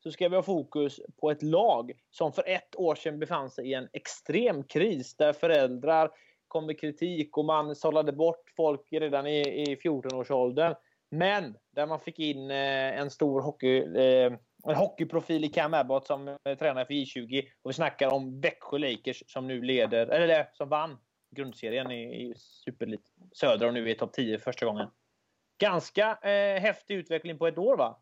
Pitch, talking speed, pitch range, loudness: 150 Hz, 180 wpm, 130-165 Hz, -29 LUFS